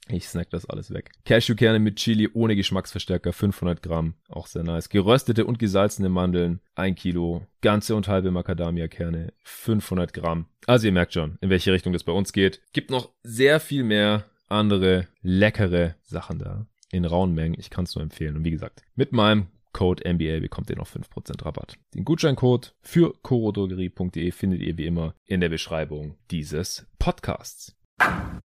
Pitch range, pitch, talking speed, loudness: 85-105 Hz, 95 Hz, 170 wpm, -24 LUFS